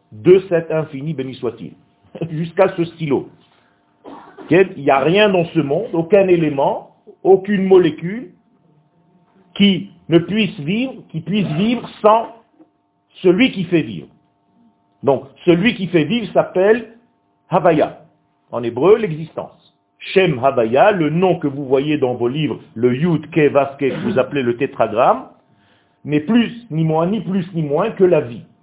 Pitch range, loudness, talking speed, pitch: 150-200 Hz, -16 LUFS, 145 wpm, 170 Hz